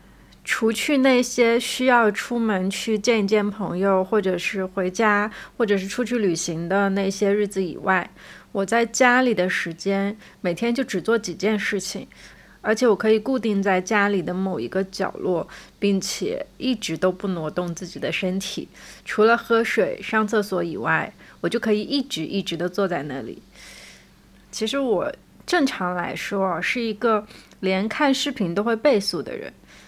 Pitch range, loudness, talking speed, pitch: 190-230 Hz, -22 LUFS, 240 characters per minute, 205 Hz